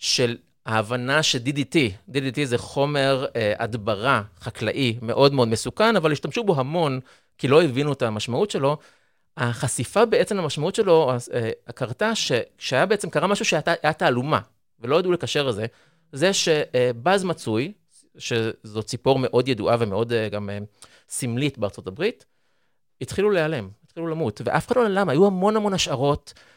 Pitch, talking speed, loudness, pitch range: 140 Hz, 150 wpm, -22 LUFS, 120-165 Hz